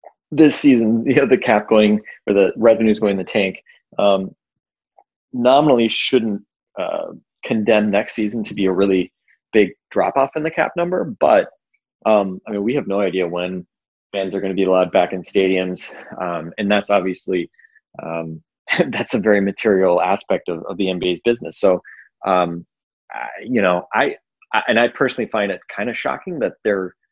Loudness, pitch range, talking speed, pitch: -18 LUFS, 95-110 Hz, 180 wpm, 100 Hz